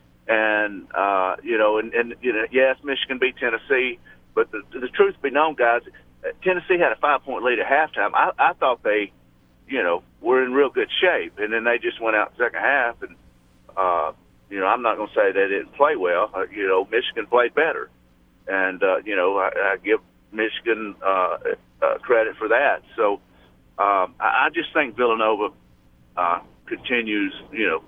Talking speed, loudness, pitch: 185 wpm, -21 LUFS, 145 Hz